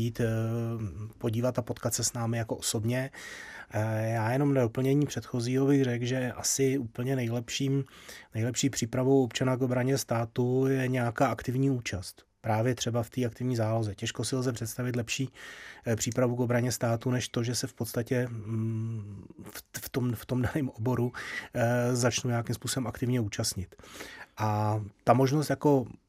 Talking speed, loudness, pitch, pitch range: 150 wpm, -30 LUFS, 120 Hz, 115-130 Hz